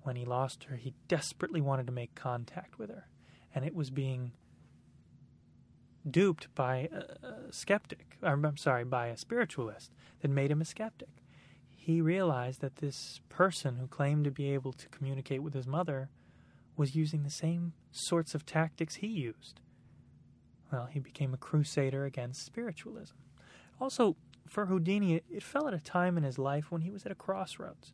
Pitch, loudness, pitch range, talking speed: 145 Hz, -35 LUFS, 135-170 Hz, 170 wpm